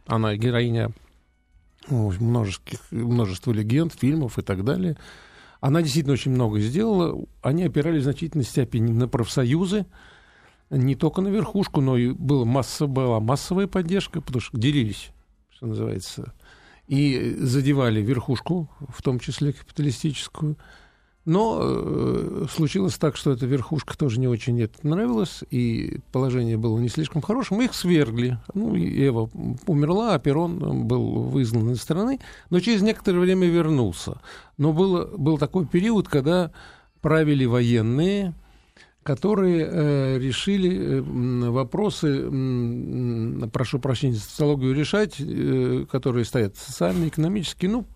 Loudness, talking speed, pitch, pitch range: -23 LUFS, 130 wpm, 140 Hz, 120-170 Hz